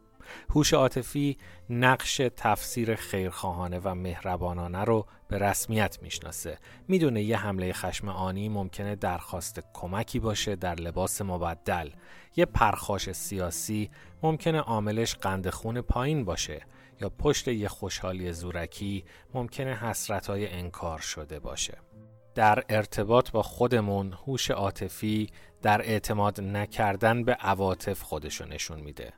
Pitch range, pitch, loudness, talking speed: 90-115 Hz, 100 Hz, -29 LUFS, 115 wpm